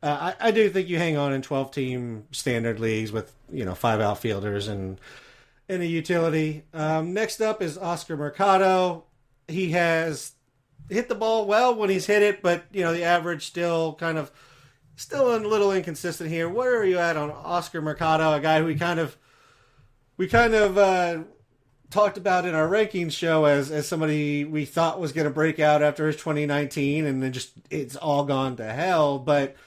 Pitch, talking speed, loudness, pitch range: 160 Hz, 190 wpm, -24 LUFS, 140-180 Hz